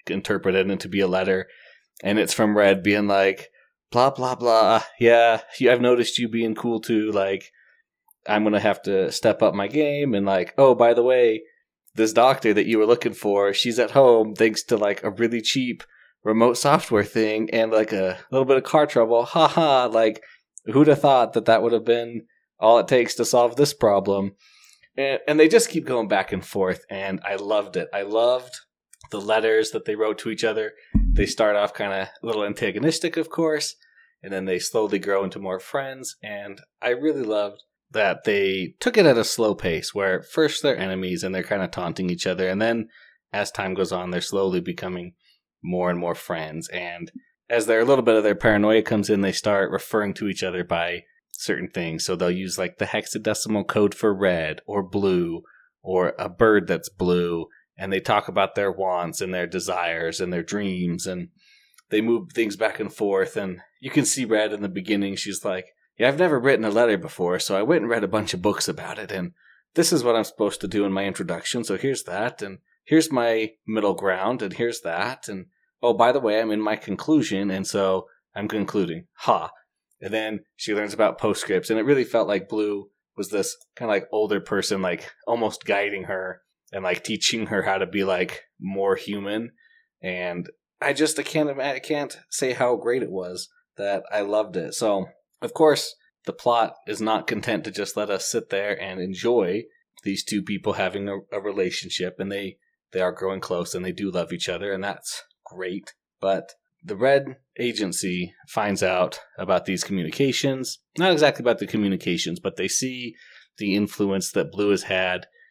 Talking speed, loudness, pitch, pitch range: 200 wpm, -23 LUFS, 105 Hz, 95-120 Hz